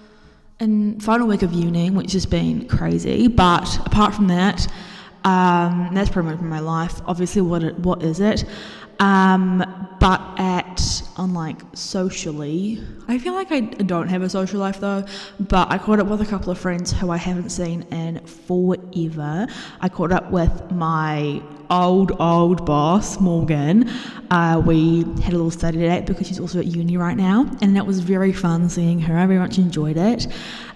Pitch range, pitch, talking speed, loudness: 170-195 Hz, 180 Hz, 175 wpm, -20 LUFS